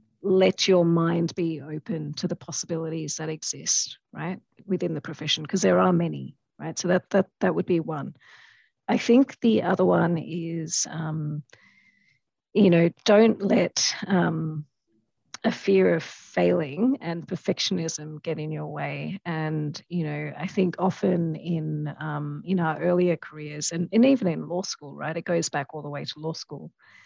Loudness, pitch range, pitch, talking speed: -25 LUFS, 155-185 Hz, 170 Hz, 170 wpm